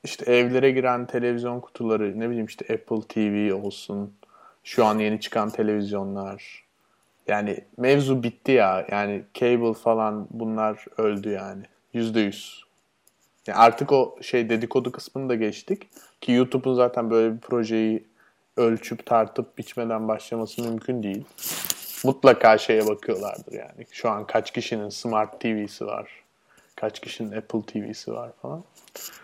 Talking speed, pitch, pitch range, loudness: 135 wpm, 115 Hz, 105-120 Hz, -24 LUFS